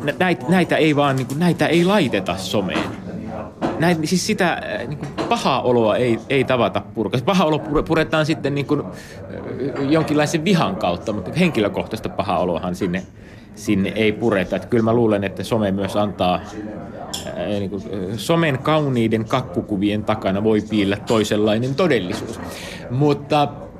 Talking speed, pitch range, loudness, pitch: 140 wpm, 105-150 Hz, -20 LUFS, 115 Hz